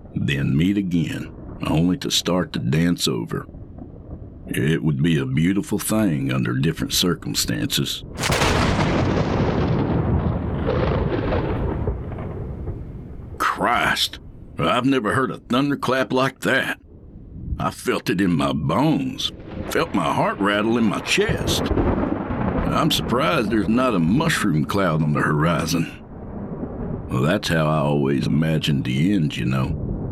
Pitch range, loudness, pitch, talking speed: 75-105 Hz, -21 LUFS, 90 Hz, 120 wpm